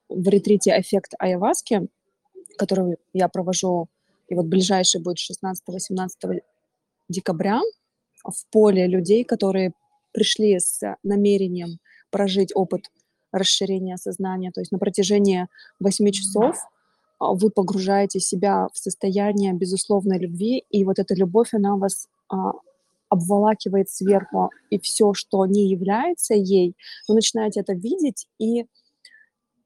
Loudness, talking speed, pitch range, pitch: -21 LUFS, 115 wpm, 190-215 Hz, 200 Hz